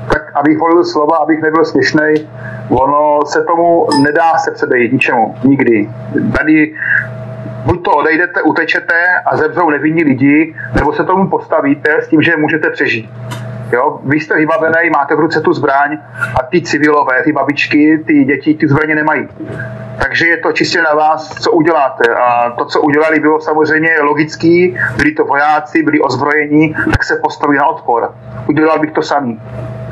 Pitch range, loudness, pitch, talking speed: 140-160 Hz, -11 LUFS, 155 Hz, 160 wpm